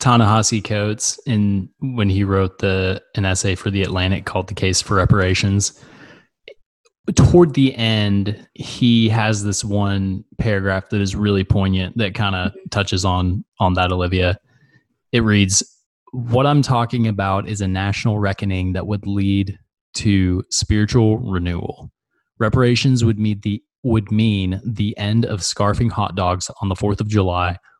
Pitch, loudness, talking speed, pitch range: 105 Hz, -18 LUFS, 150 wpm, 95-115 Hz